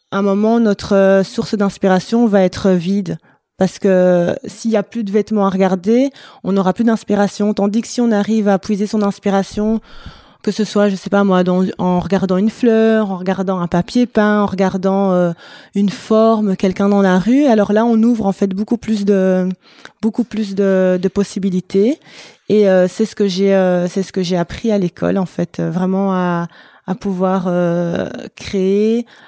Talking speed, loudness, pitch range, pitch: 190 wpm, -15 LUFS, 190-215 Hz, 200 Hz